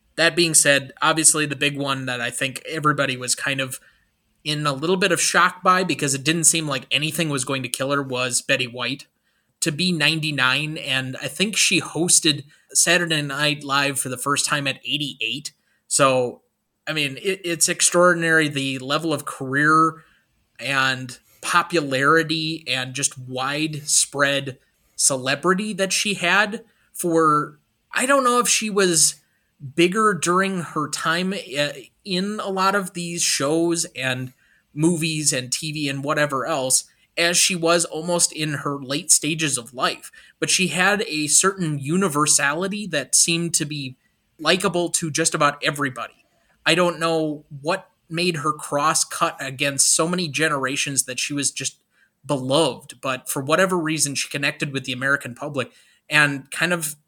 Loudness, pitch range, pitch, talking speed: -20 LUFS, 140-170 Hz, 150 Hz, 160 wpm